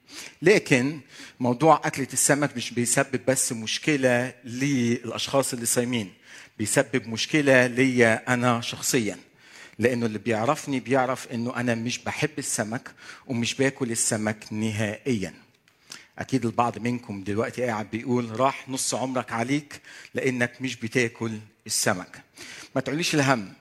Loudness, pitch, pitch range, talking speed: -25 LUFS, 125 Hz, 115-135 Hz, 115 wpm